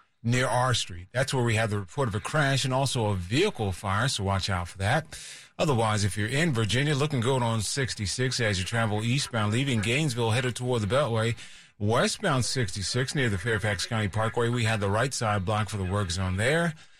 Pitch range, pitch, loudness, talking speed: 105-130 Hz, 115 Hz, -27 LUFS, 215 wpm